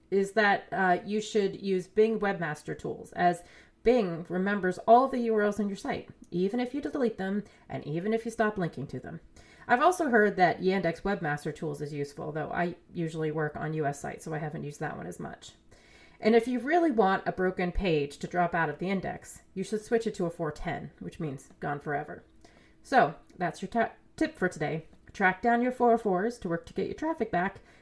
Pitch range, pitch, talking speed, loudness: 165-215 Hz, 185 Hz, 210 wpm, -29 LUFS